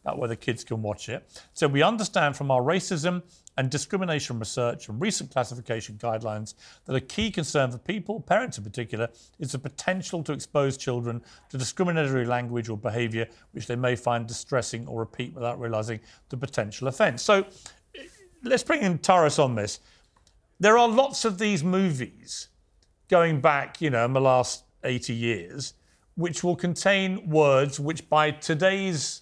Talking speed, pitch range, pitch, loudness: 165 wpm, 115-175 Hz, 135 Hz, -26 LUFS